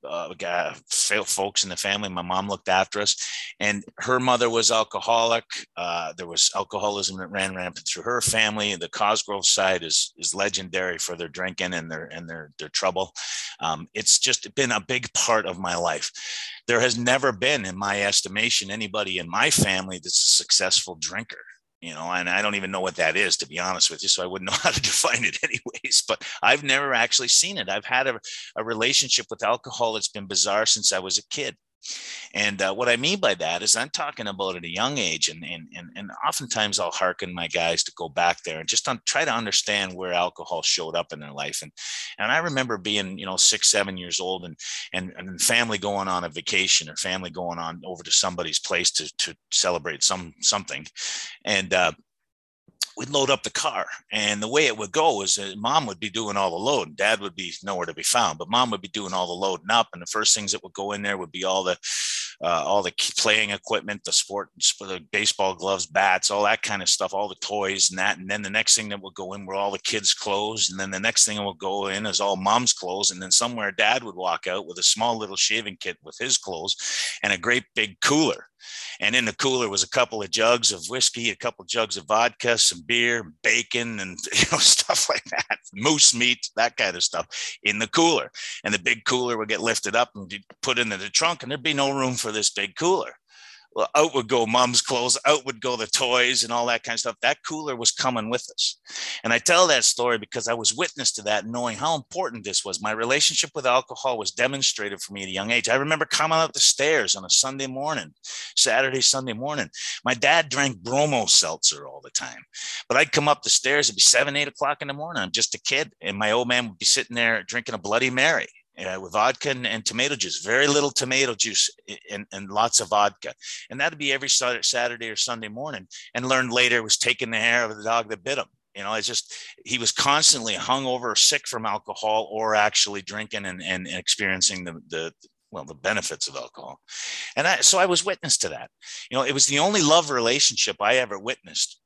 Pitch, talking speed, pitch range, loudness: 110 Hz, 230 wpm, 95-125 Hz, -22 LUFS